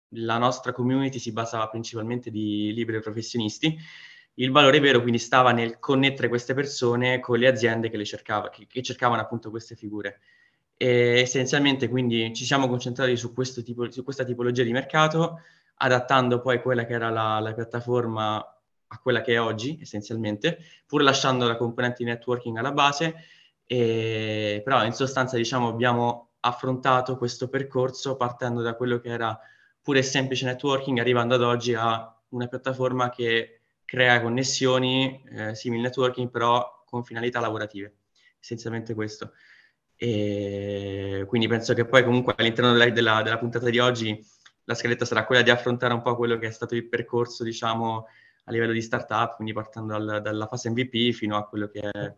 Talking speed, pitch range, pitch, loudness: 165 wpm, 115-125 Hz, 120 Hz, -24 LUFS